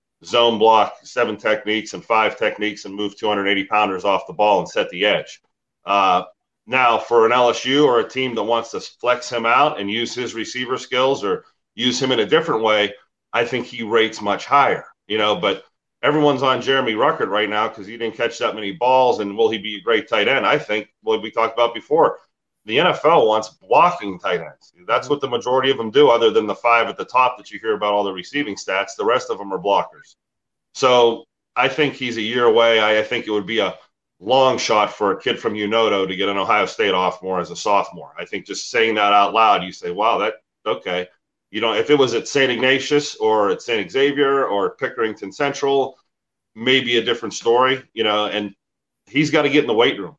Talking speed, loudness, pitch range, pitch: 225 wpm, -18 LUFS, 105-135 Hz, 120 Hz